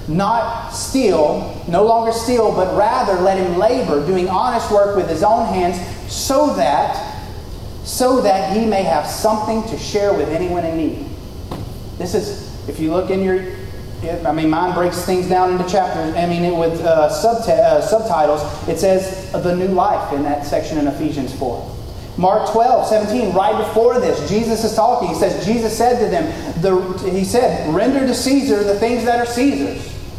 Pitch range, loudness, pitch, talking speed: 165-220 Hz, -17 LUFS, 190 Hz, 180 wpm